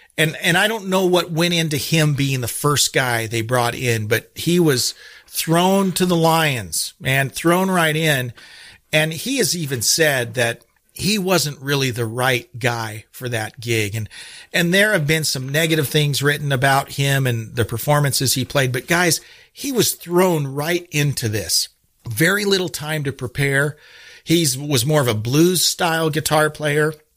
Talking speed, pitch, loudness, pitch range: 175 wpm, 150 Hz, -18 LUFS, 125-165 Hz